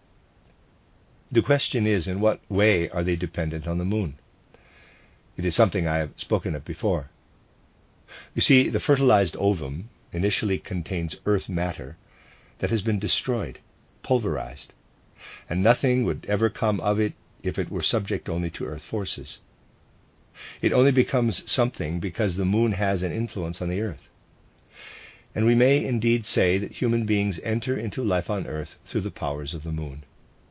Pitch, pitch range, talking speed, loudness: 100 Hz, 85-115 Hz, 160 wpm, -25 LUFS